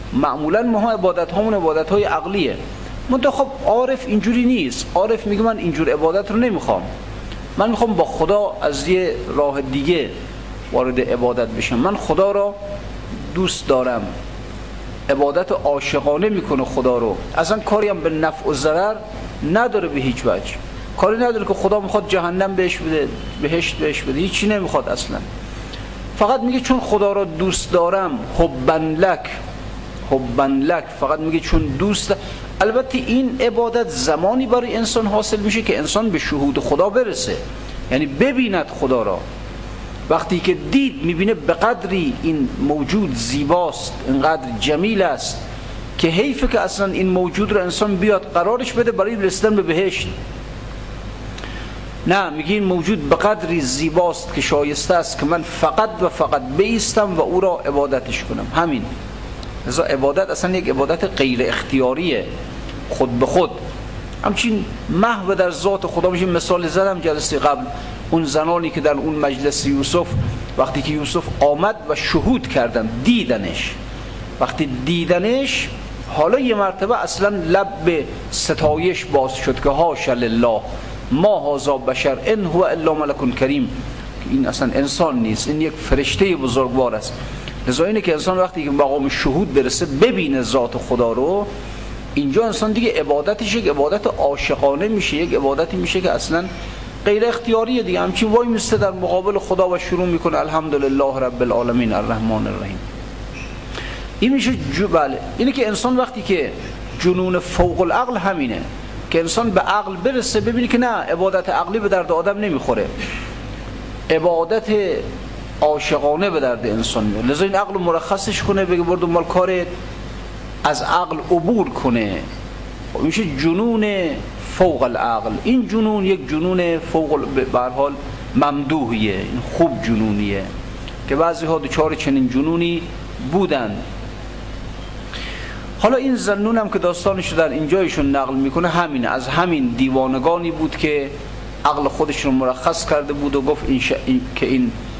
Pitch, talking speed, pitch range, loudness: 170 Hz, 145 wpm, 140-205 Hz, -18 LUFS